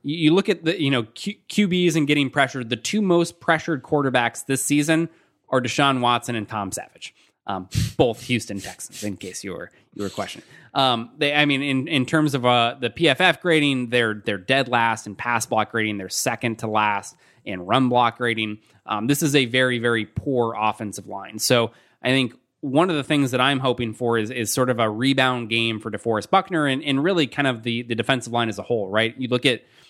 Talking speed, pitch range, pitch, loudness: 220 wpm, 115-145 Hz, 125 Hz, -21 LUFS